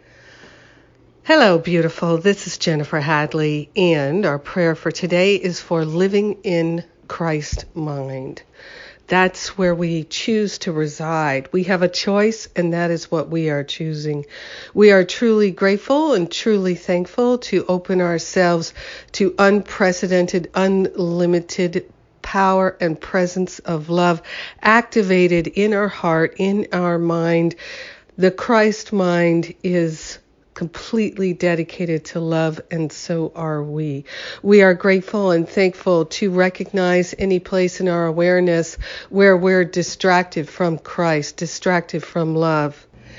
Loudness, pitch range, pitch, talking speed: -18 LUFS, 165-190 Hz, 175 Hz, 125 wpm